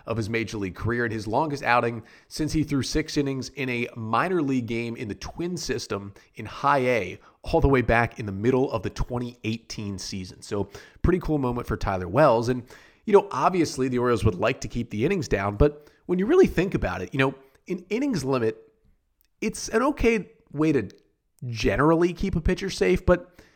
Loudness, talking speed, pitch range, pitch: -25 LUFS, 205 wpm, 115-165 Hz, 130 Hz